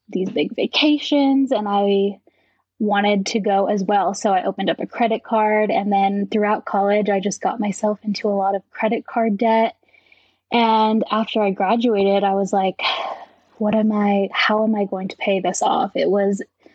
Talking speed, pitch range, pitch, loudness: 185 wpm, 200-220 Hz, 210 Hz, -19 LUFS